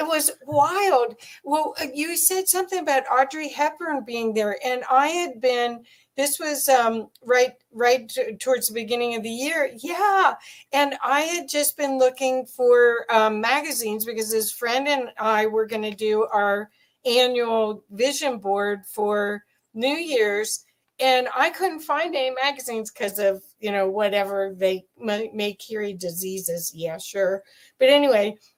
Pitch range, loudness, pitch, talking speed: 215-280 Hz, -22 LUFS, 245 Hz, 155 wpm